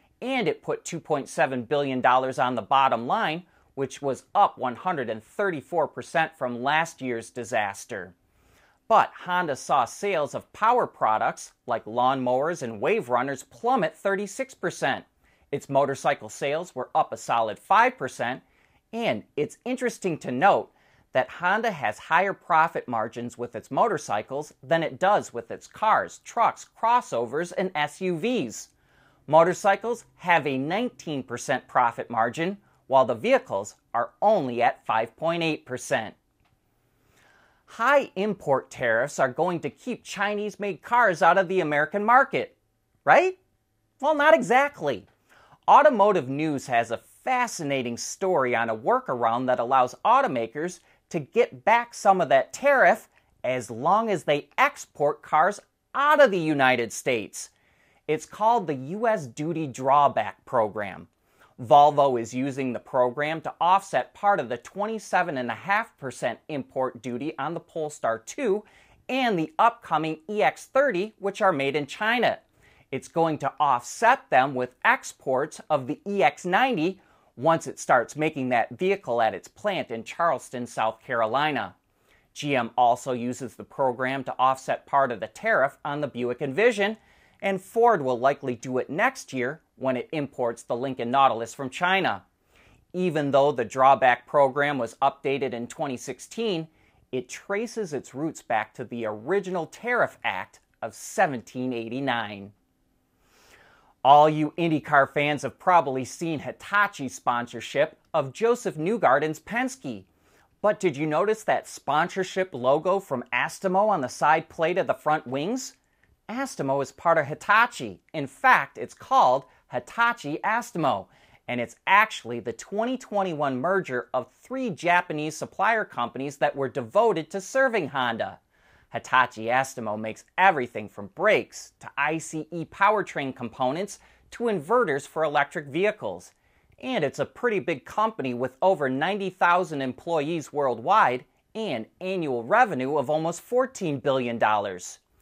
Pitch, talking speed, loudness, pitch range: 150 Hz, 135 wpm, -25 LUFS, 130-195 Hz